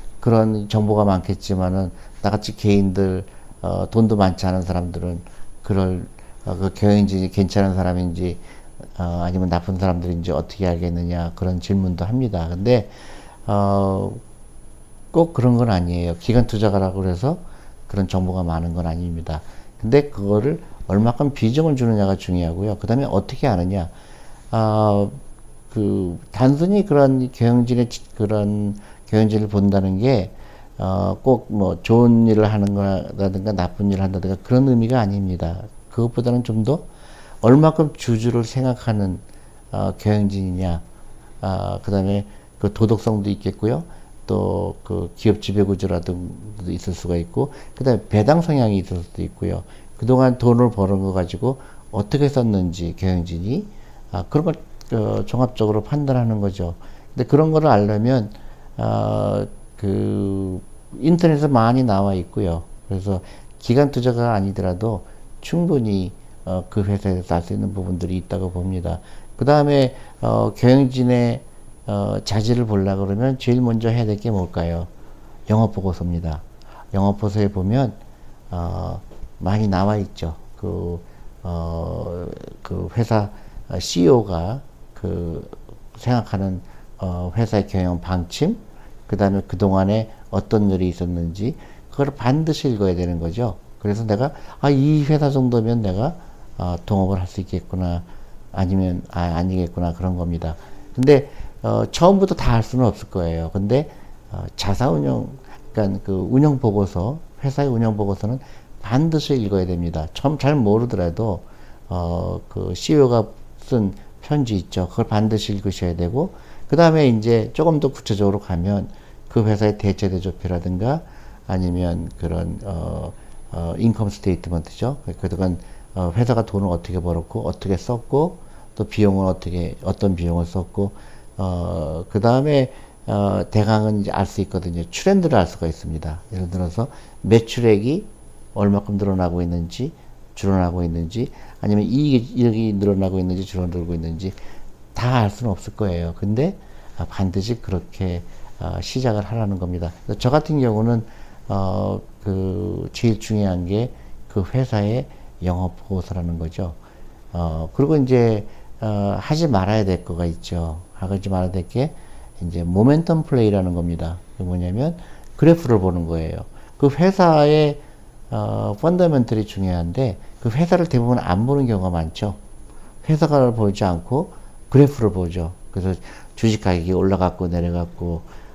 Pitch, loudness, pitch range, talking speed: 100 Hz, -20 LUFS, 90-120 Hz, 300 characters per minute